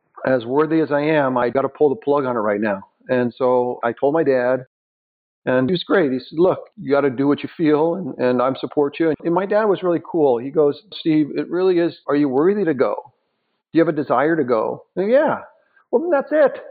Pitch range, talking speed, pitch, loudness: 130-170 Hz, 255 wpm, 145 Hz, -19 LUFS